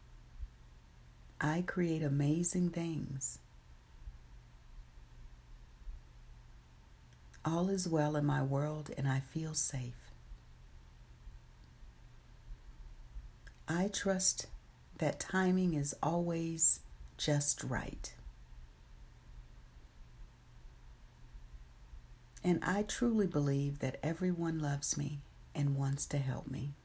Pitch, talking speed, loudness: 135 Hz, 80 wpm, -34 LUFS